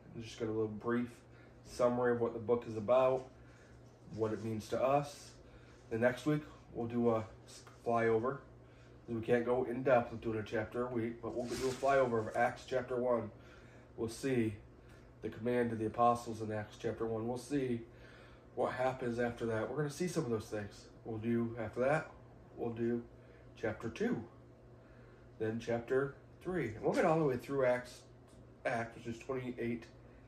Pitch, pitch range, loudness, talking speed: 120 Hz, 115-125 Hz, -37 LUFS, 180 wpm